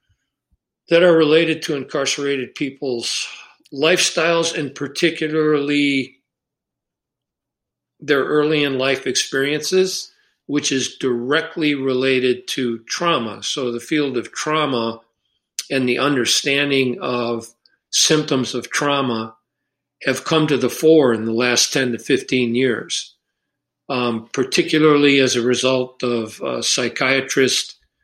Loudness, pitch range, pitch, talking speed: -18 LUFS, 125-150 Hz, 135 Hz, 110 wpm